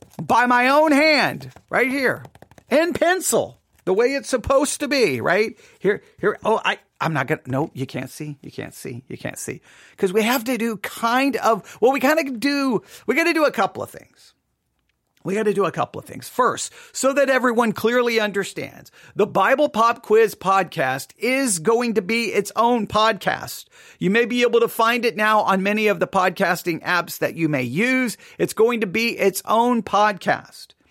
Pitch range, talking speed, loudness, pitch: 195-255 Hz, 200 wpm, -20 LUFS, 225 Hz